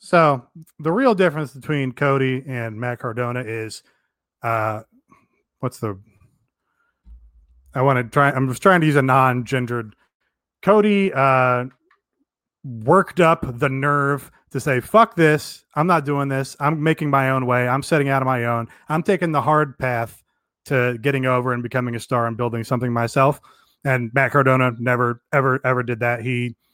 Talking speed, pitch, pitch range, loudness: 170 wpm, 130 Hz, 120-145 Hz, -20 LUFS